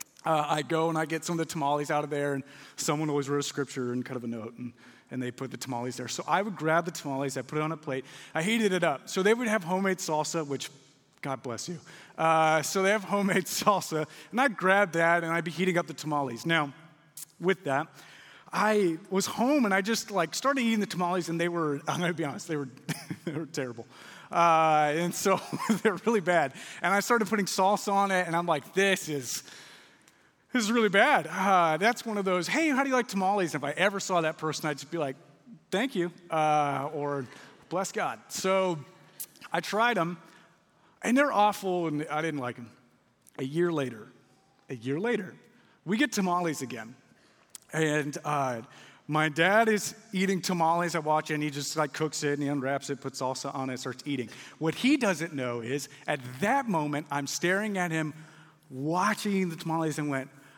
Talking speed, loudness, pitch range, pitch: 210 wpm, -29 LUFS, 145-190 Hz, 160 Hz